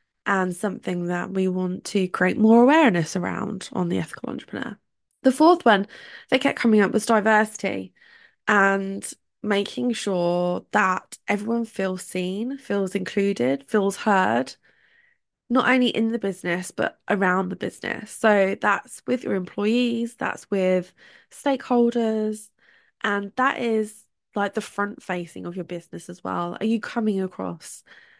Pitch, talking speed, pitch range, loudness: 205 Hz, 145 wpm, 185-230 Hz, -23 LUFS